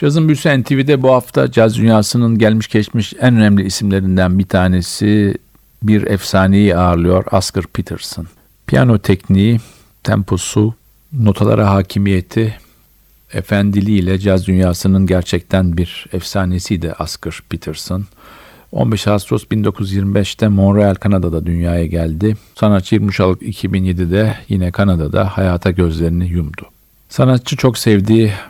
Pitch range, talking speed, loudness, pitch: 90-110 Hz, 110 wpm, -14 LUFS, 100 Hz